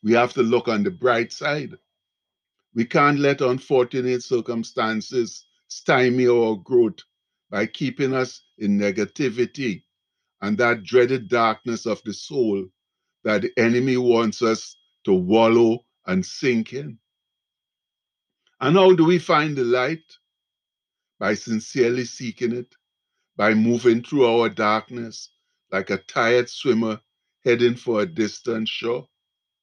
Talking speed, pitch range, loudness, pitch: 130 wpm, 110-125 Hz, -21 LUFS, 120 Hz